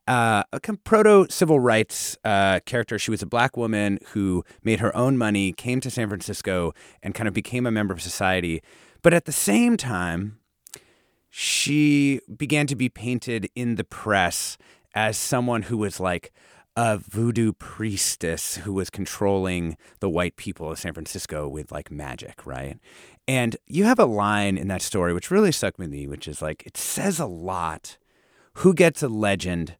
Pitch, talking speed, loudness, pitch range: 105 Hz, 180 wpm, -23 LUFS, 90-125 Hz